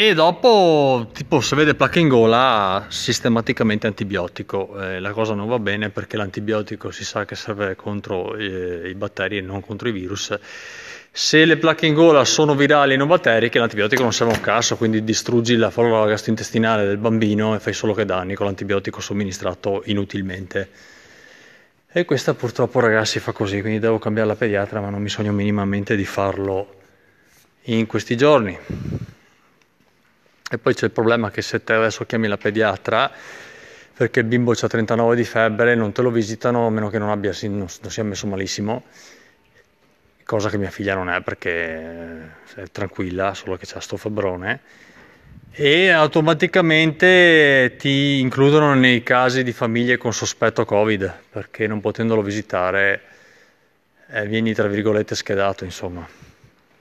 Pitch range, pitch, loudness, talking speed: 100-120 Hz, 110 Hz, -19 LUFS, 160 wpm